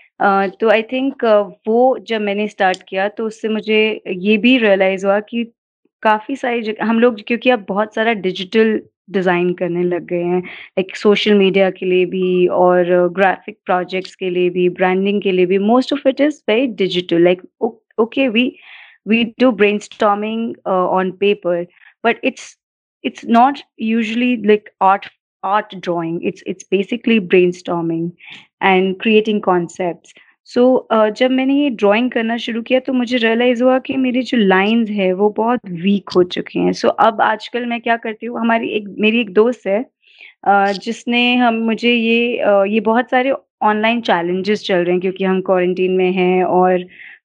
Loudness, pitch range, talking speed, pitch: -16 LUFS, 185-235 Hz, 165 wpm, 210 Hz